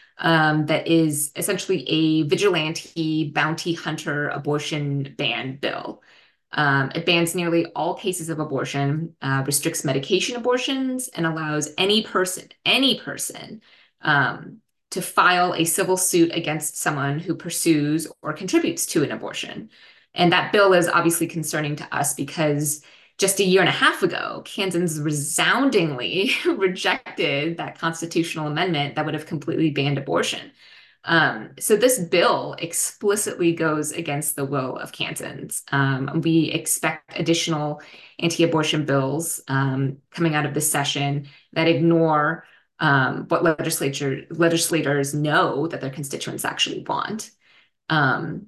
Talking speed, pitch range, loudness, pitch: 130 wpm, 150-175 Hz, -22 LUFS, 160 Hz